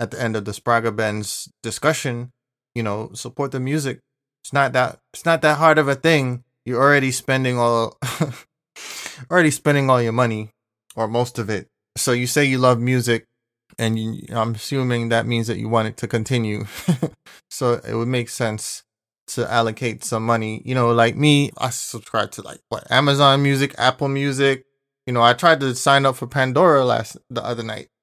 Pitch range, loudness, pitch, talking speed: 115-140 Hz, -20 LUFS, 125 Hz, 190 wpm